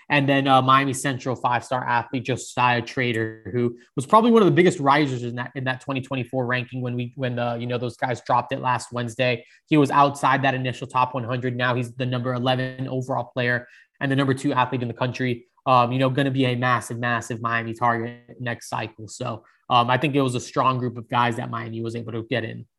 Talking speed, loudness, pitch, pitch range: 230 wpm, -23 LUFS, 125 Hz, 120-130 Hz